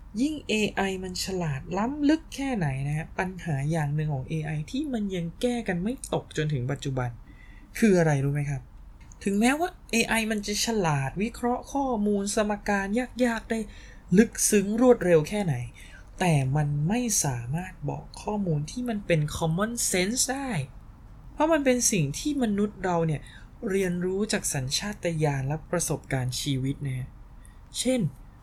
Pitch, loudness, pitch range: 180 Hz, -27 LUFS, 140-220 Hz